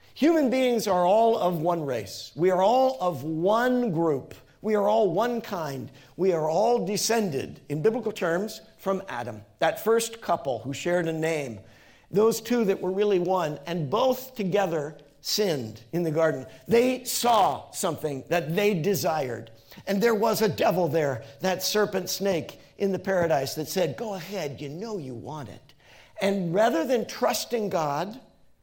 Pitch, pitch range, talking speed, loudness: 185 Hz, 155-215 Hz, 165 wpm, -26 LUFS